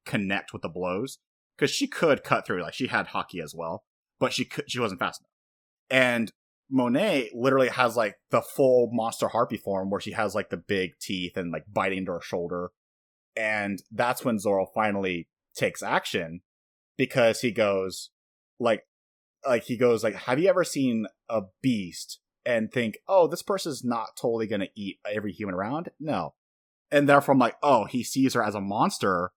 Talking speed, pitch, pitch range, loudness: 185 wpm, 105 Hz, 95-125 Hz, -27 LUFS